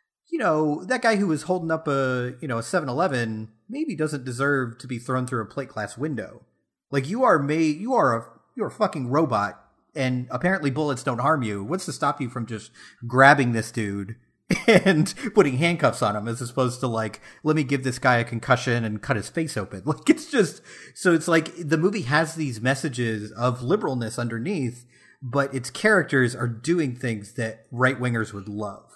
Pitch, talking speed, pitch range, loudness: 130 Hz, 200 wpm, 120-155 Hz, -24 LUFS